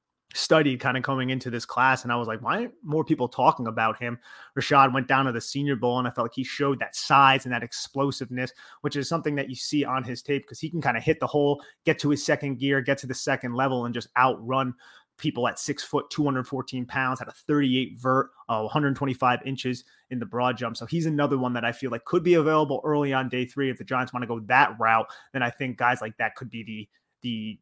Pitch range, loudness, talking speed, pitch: 120-140 Hz, -25 LUFS, 260 wpm, 130 Hz